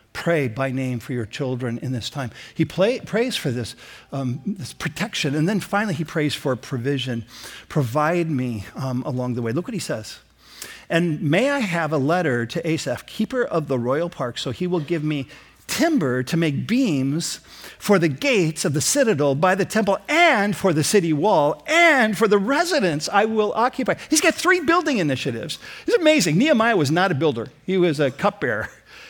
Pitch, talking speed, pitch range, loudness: 165 Hz, 190 wpm, 135-210 Hz, -21 LUFS